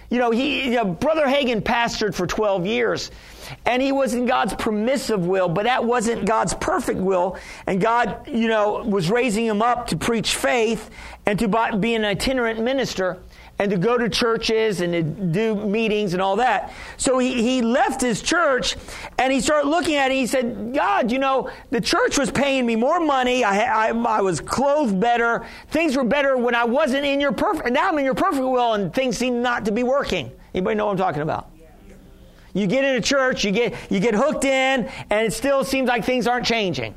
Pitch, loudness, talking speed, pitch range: 235 Hz, -21 LUFS, 215 wpm, 215-265 Hz